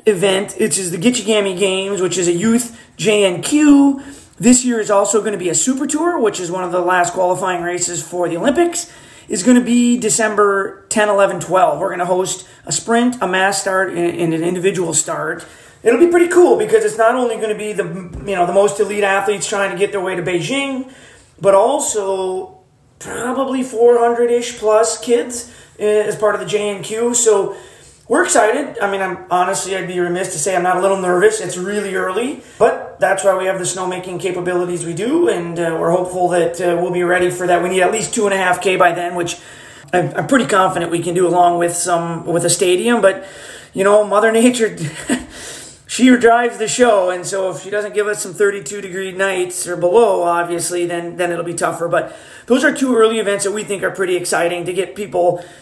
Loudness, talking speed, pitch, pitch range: -16 LUFS, 215 wpm, 195 Hz, 180-220 Hz